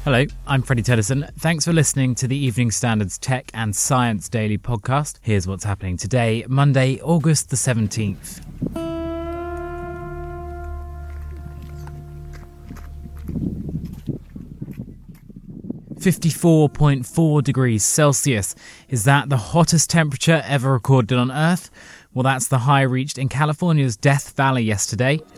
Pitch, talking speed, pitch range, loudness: 125 Hz, 110 wpm, 90-140 Hz, -19 LUFS